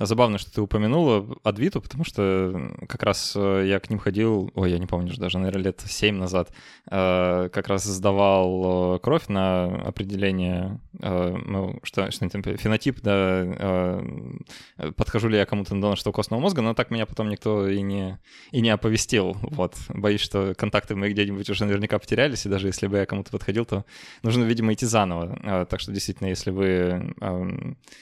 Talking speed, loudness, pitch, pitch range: 175 wpm, -24 LUFS, 100 Hz, 95-110 Hz